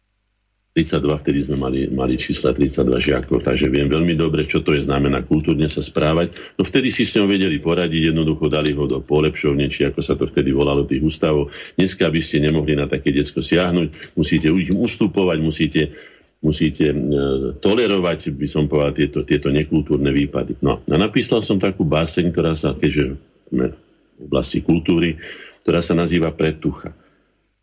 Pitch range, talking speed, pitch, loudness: 70-80 Hz, 170 wpm, 75 Hz, -19 LUFS